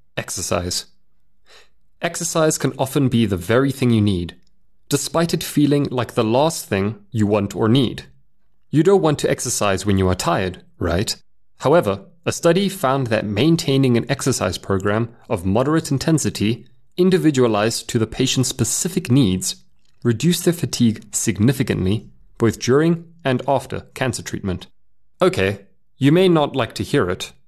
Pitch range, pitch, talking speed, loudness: 105-145 Hz, 125 Hz, 145 wpm, -19 LUFS